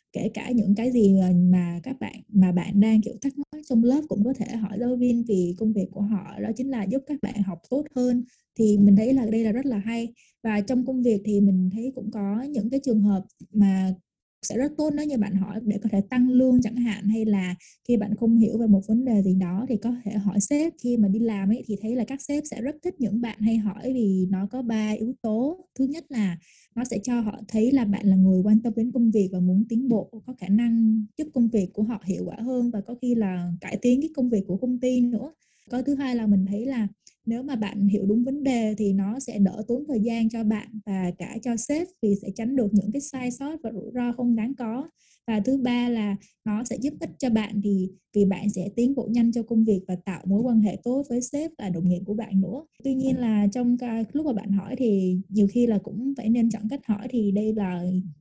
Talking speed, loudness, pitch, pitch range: 260 wpm, -24 LUFS, 225 Hz, 205-245 Hz